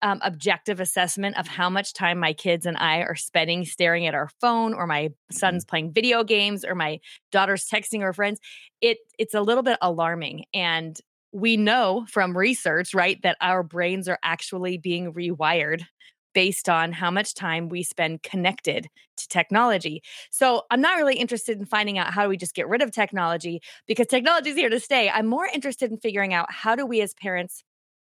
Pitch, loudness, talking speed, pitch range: 185 Hz, -23 LUFS, 195 wpm, 170-220 Hz